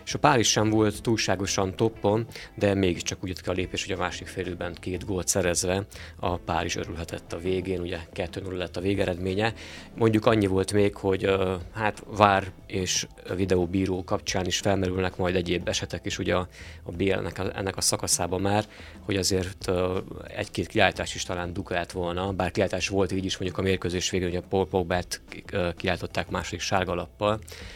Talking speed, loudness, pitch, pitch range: 175 wpm, -27 LUFS, 95 Hz, 90-100 Hz